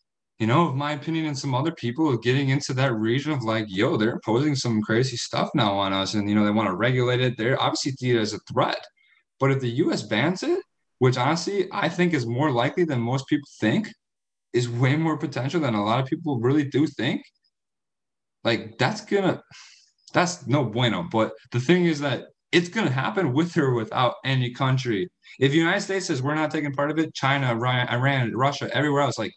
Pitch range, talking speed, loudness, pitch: 120-155 Hz, 215 wpm, -24 LUFS, 135 Hz